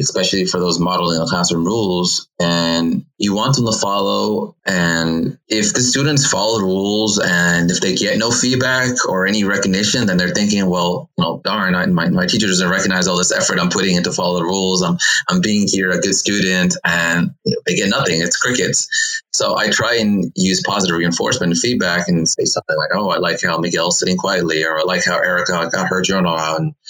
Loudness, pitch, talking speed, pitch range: -16 LUFS, 95 Hz, 210 wpm, 85-105 Hz